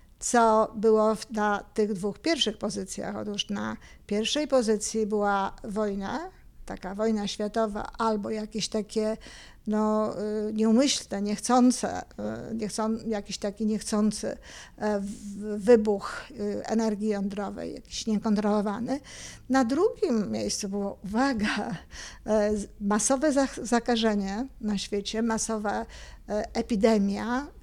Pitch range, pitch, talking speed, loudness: 205-225 Hz, 215 Hz, 90 wpm, -27 LUFS